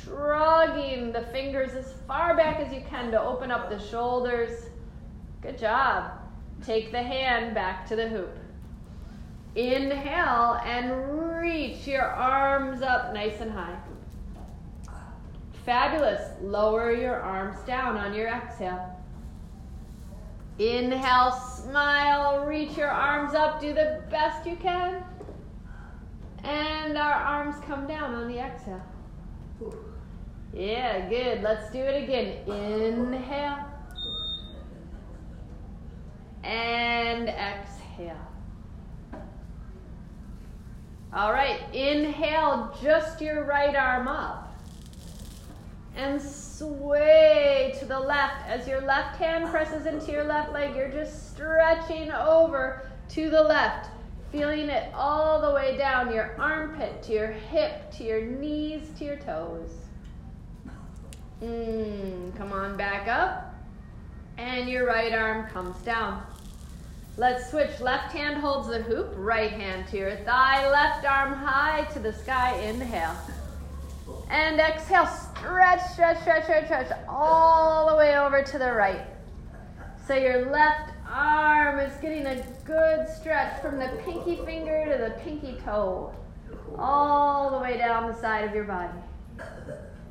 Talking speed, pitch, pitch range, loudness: 125 wpm, 265 Hz, 225-300 Hz, -26 LUFS